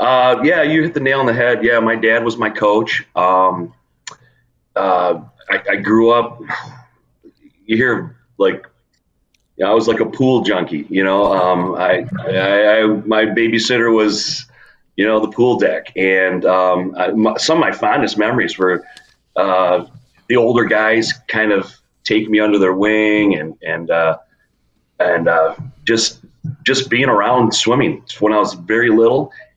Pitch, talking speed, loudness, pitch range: 110 Hz, 165 wpm, -15 LUFS, 95-120 Hz